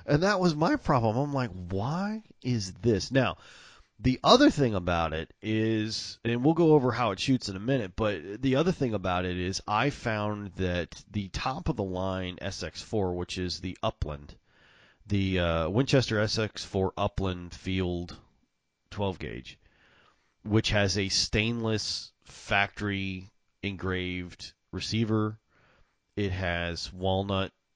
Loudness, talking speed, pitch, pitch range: -29 LUFS, 140 wpm, 100 Hz, 90-115 Hz